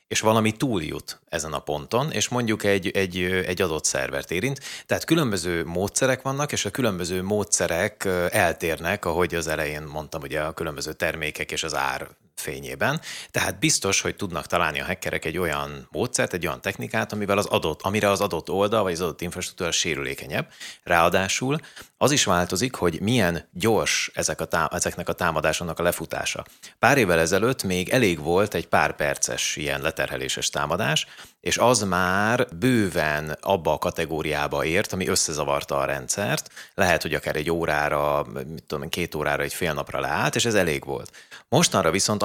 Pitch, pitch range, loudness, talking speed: 90 Hz, 80-105 Hz, -24 LUFS, 165 wpm